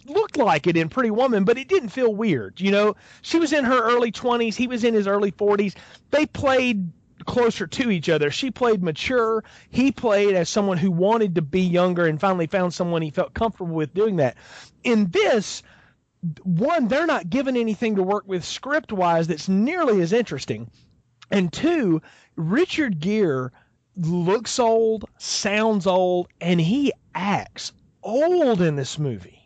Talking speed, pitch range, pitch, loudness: 170 wpm, 175-245 Hz, 205 Hz, -22 LUFS